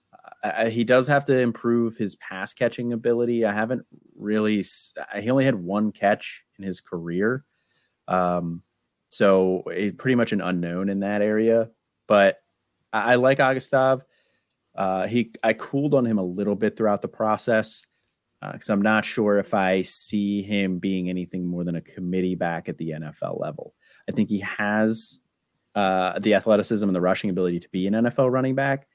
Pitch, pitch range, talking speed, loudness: 105 Hz, 95-120 Hz, 175 wpm, -23 LUFS